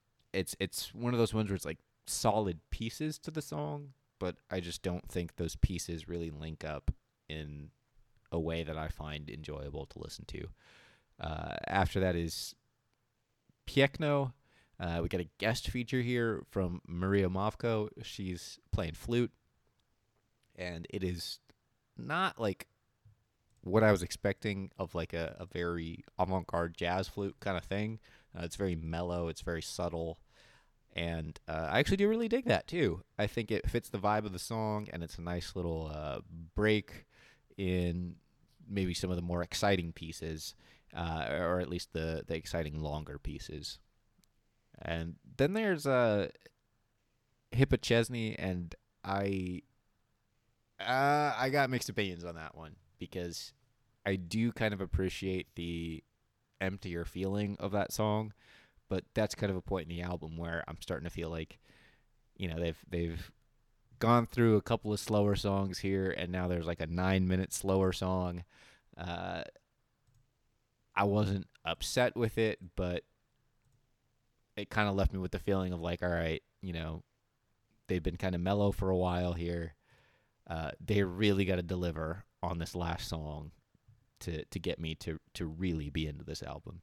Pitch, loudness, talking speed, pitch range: 95 Hz, -35 LUFS, 165 wpm, 85-110 Hz